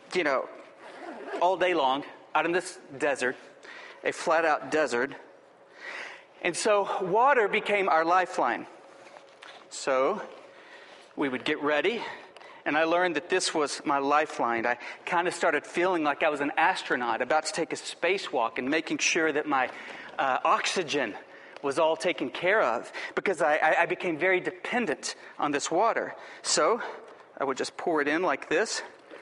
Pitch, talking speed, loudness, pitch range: 175 Hz, 160 wpm, -27 LUFS, 155-210 Hz